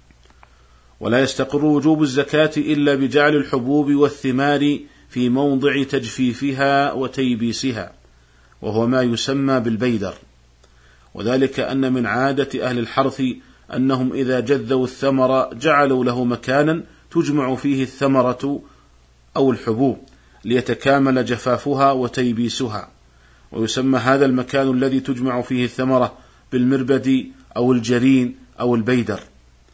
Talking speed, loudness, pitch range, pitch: 100 wpm, -19 LUFS, 120-135 Hz, 130 Hz